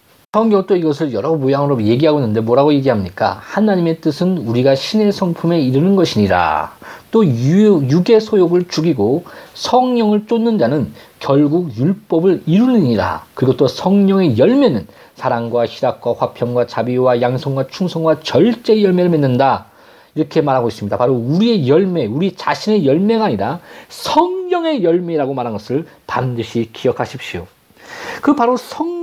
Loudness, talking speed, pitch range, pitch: -15 LUFS, 335 characters per minute, 130-210 Hz, 165 Hz